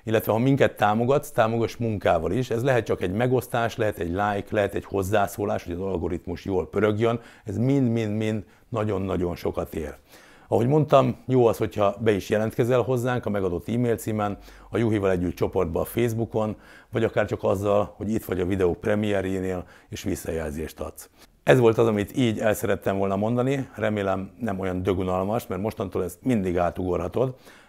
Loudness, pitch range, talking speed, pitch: -25 LUFS, 95-115 Hz, 170 wpm, 105 Hz